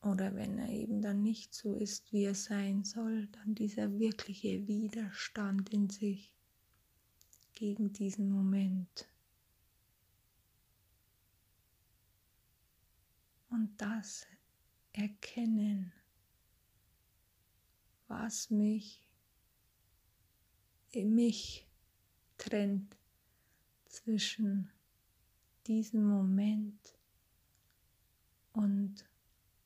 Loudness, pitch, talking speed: -36 LUFS, 195 Hz, 65 wpm